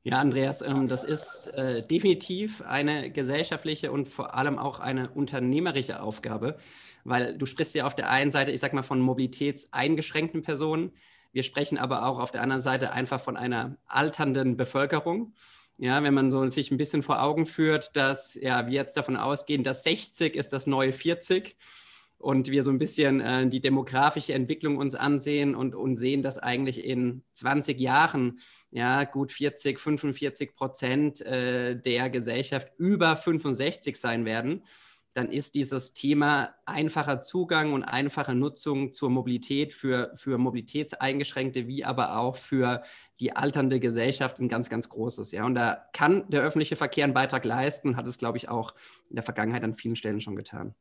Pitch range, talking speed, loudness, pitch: 130-145 Hz, 170 wpm, -28 LUFS, 135 Hz